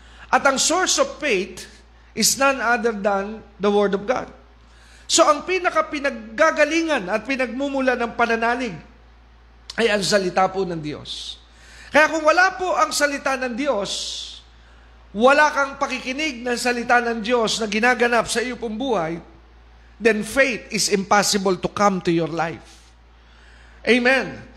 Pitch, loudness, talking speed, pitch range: 230 Hz, -20 LUFS, 140 wpm, 180-270 Hz